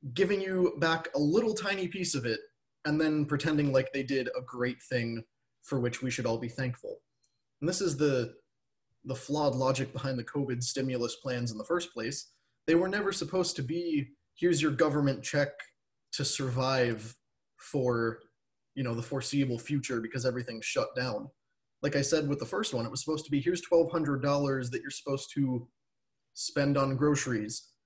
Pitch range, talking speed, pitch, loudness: 125-150 Hz, 180 wpm, 135 Hz, -31 LUFS